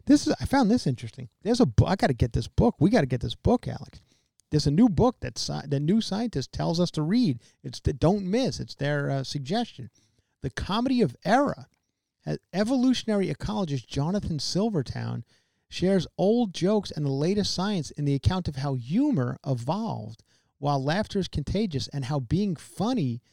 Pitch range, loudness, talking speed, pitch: 135-205 Hz, -26 LUFS, 185 wpm, 155 Hz